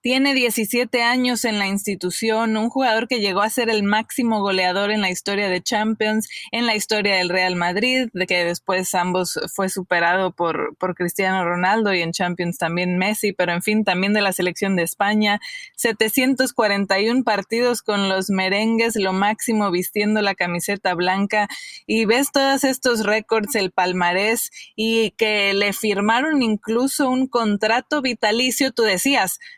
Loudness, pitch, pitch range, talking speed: -20 LUFS, 210 Hz, 190-230 Hz, 160 wpm